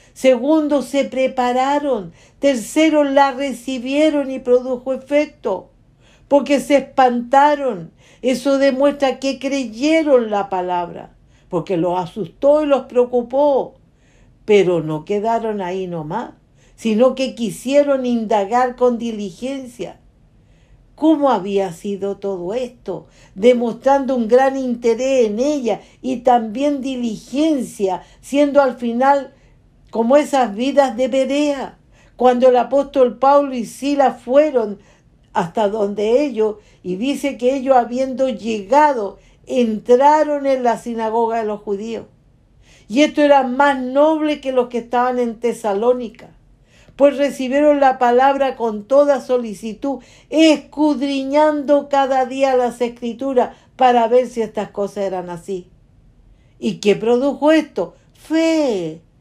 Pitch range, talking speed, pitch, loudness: 220-275 Hz, 115 wpm, 250 Hz, -17 LUFS